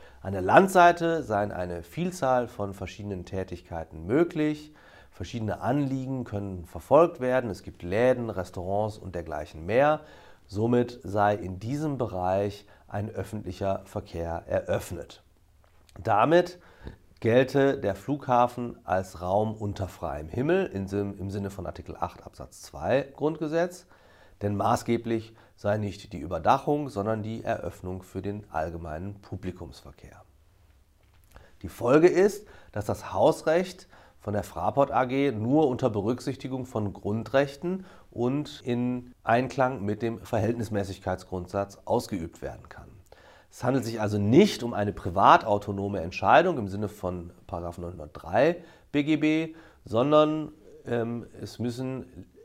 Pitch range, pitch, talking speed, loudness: 95-130 Hz, 105 Hz, 120 wpm, -27 LUFS